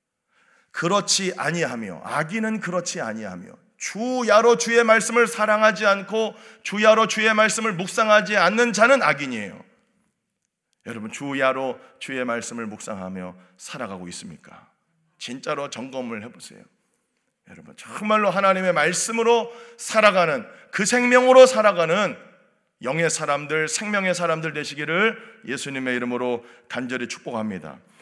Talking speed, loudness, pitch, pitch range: 305 characters per minute, -20 LUFS, 190 Hz, 140-220 Hz